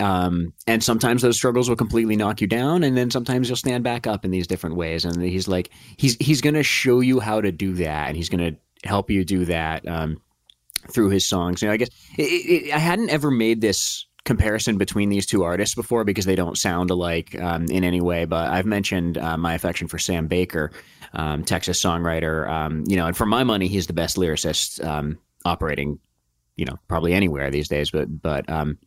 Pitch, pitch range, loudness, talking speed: 90 Hz, 85-115 Hz, -22 LUFS, 220 wpm